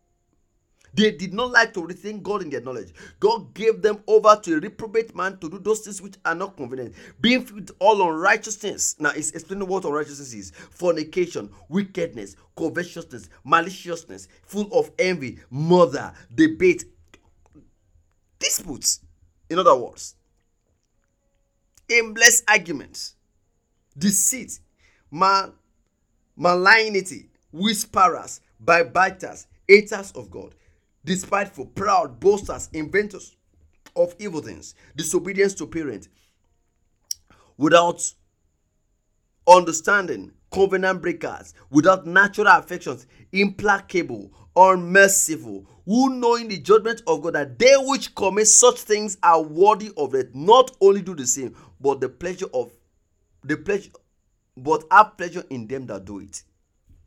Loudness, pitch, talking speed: -20 LUFS, 175 Hz, 120 wpm